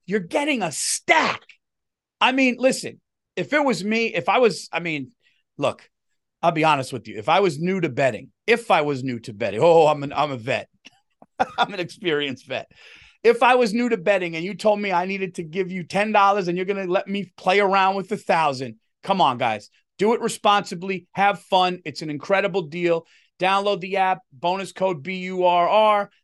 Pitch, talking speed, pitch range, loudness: 190 Hz, 210 wpm, 170-210 Hz, -21 LUFS